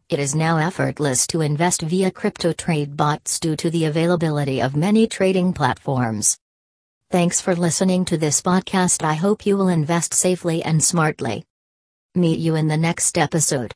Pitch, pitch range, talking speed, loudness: 165 Hz, 150-180 Hz, 165 wpm, -19 LUFS